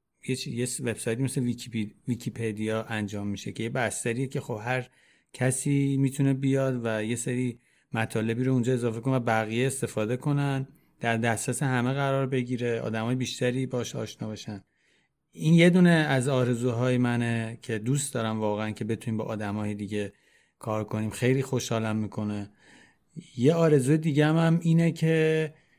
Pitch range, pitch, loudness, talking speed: 110-135 Hz, 125 Hz, -27 LUFS, 150 wpm